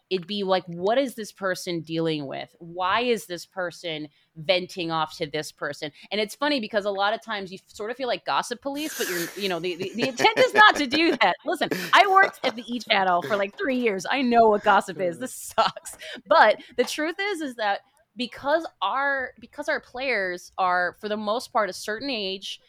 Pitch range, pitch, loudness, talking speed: 180-260 Hz, 205 Hz, -24 LUFS, 220 wpm